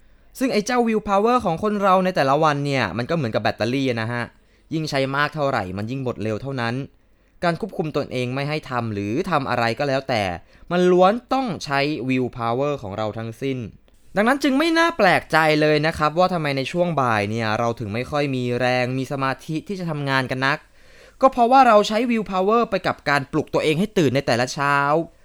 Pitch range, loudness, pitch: 125-185 Hz, -21 LUFS, 140 Hz